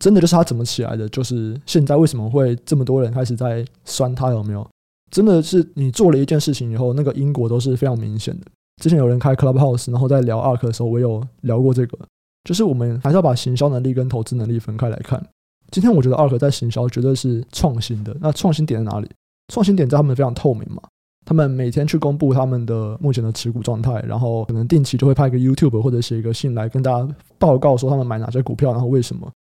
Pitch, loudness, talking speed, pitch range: 130 Hz, -18 LUFS, 405 characters per minute, 120-145 Hz